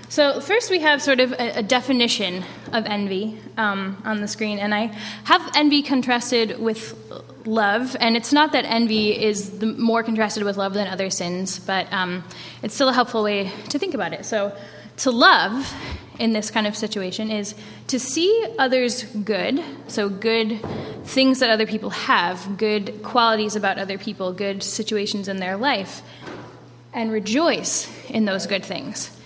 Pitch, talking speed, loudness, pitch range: 220 Hz, 170 wpm, -21 LUFS, 205-245 Hz